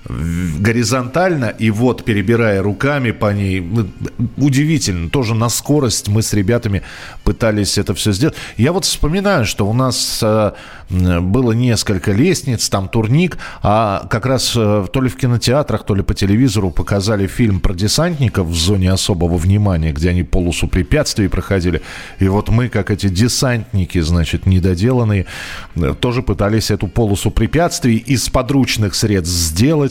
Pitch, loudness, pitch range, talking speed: 105 Hz, -15 LUFS, 95-125 Hz, 140 wpm